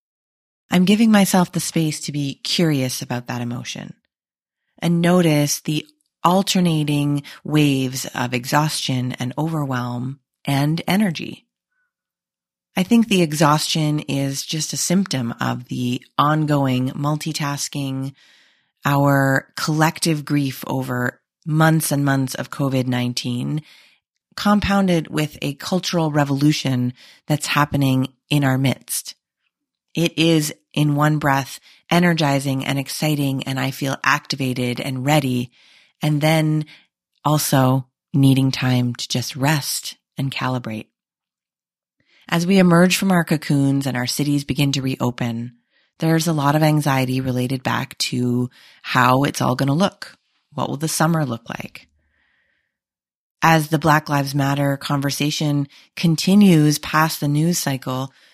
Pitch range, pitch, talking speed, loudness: 130-160 Hz, 145 Hz, 125 wpm, -19 LUFS